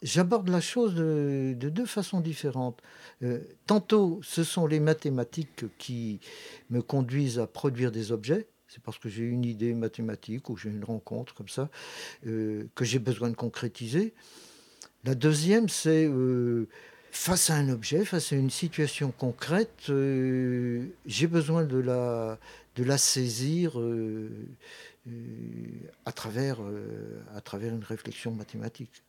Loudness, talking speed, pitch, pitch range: -29 LUFS, 145 wpm, 130 Hz, 115-155 Hz